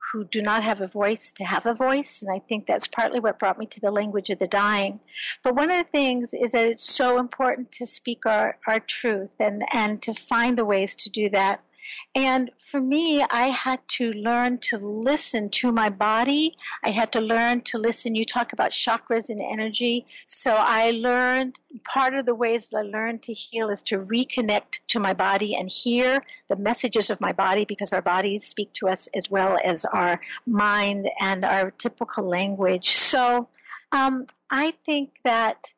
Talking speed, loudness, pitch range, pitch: 195 wpm, -24 LUFS, 205-250 Hz, 230 Hz